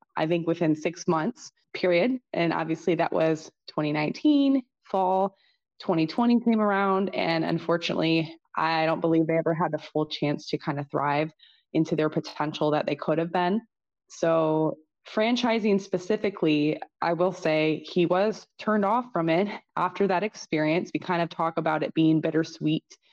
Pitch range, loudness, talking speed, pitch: 155-195 Hz, -26 LUFS, 160 wpm, 165 Hz